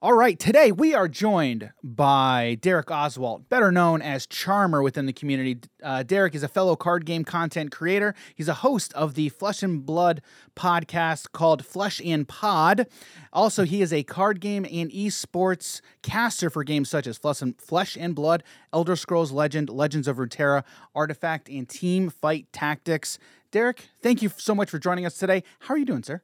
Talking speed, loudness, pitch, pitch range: 185 wpm, -24 LUFS, 165 Hz, 150-195 Hz